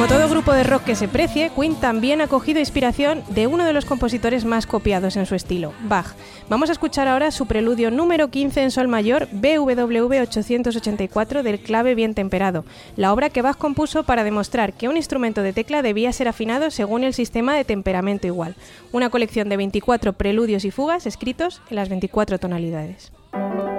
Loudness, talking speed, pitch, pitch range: -20 LUFS, 185 wpm, 235 Hz, 205-275 Hz